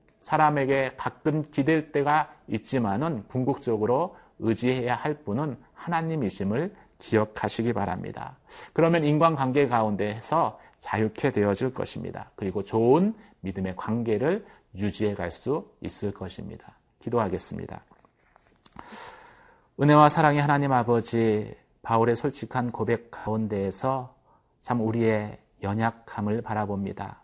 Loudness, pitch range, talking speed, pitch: -26 LUFS, 105-145 Hz, 285 characters per minute, 115 Hz